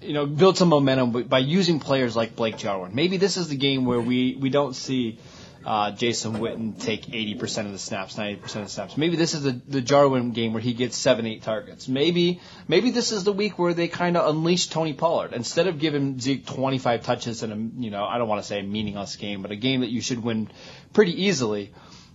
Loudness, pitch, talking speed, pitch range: -24 LUFS, 130 Hz, 240 wpm, 110-155 Hz